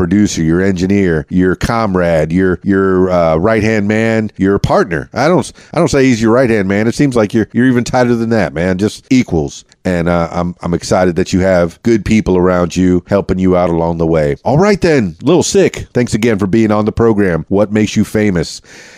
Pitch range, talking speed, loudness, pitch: 90-110 Hz, 220 wpm, -12 LUFS, 100 Hz